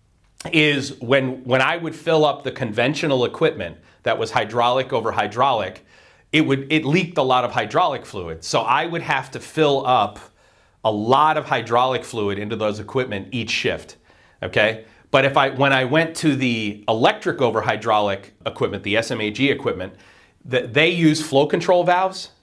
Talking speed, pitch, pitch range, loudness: 170 wpm, 130 Hz, 115-150 Hz, -20 LUFS